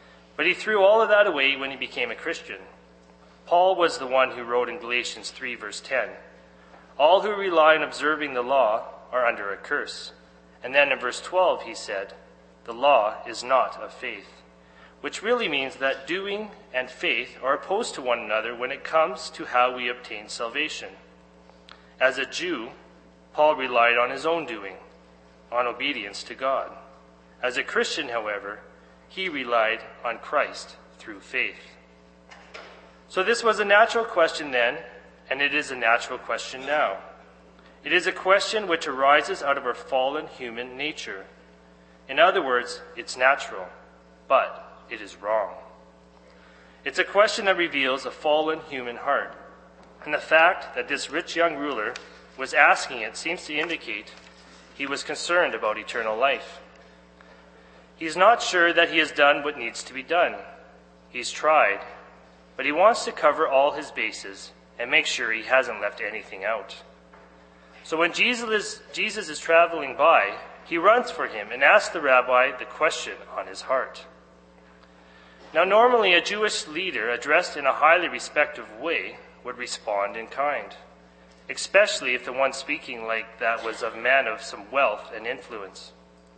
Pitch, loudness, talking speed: 120 Hz, -23 LUFS, 165 wpm